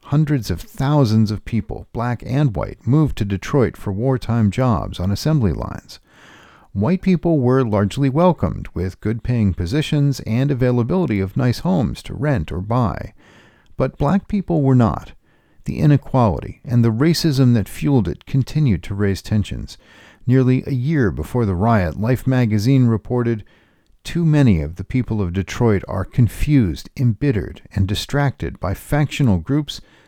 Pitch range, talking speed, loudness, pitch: 100-140 Hz, 150 wpm, -19 LUFS, 120 Hz